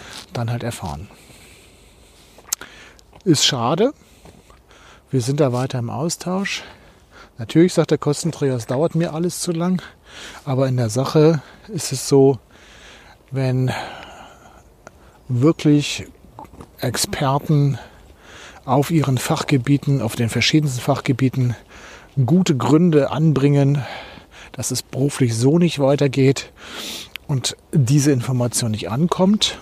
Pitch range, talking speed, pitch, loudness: 125-155 Hz, 105 wpm, 140 Hz, -19 LUFS